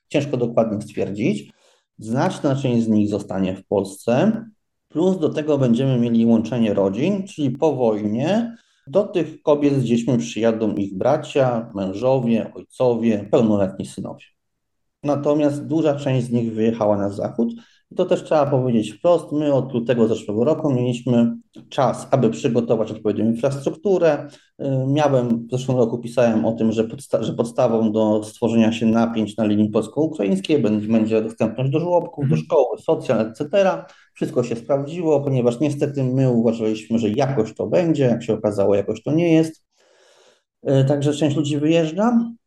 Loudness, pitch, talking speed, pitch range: -20 LUFS, 125 Hz, 145 wpm, 110-150 Hz